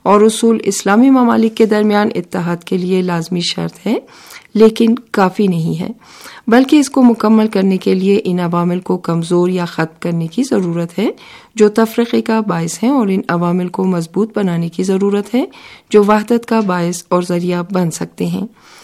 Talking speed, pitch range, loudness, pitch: 180 wpm, 175-225 Hz, -14 LUFS, 195 Hz